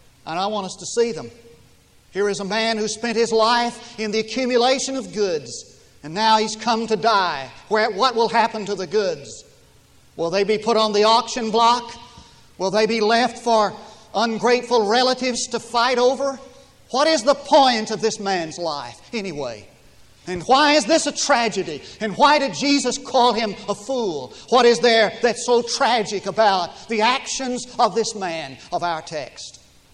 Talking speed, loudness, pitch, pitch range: 180 wpm, -20 LUFS, 230 Hz, 210-245 Hz